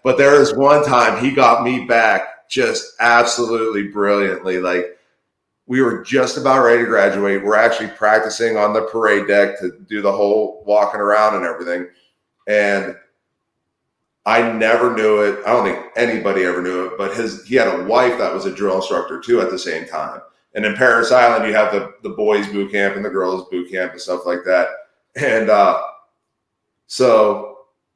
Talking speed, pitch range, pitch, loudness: 185 wpm, 100-115 Hz, 105 Hz, -16 LUFS